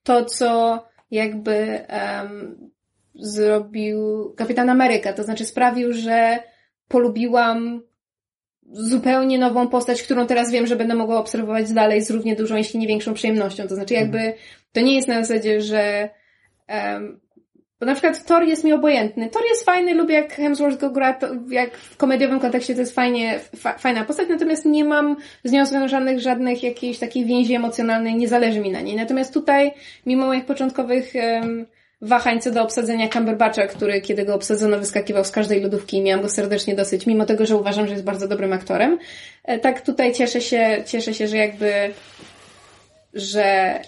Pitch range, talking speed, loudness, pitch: 215-255 Hz, 170 wpm, -20 LUFS, 235 Hz